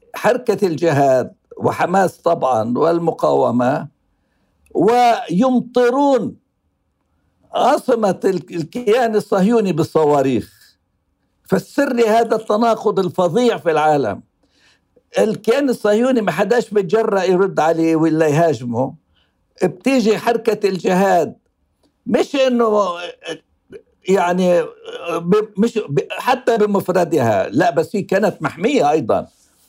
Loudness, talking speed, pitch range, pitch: -17 LUFS, 80 wpm, 165-235 Hz, 200 Hz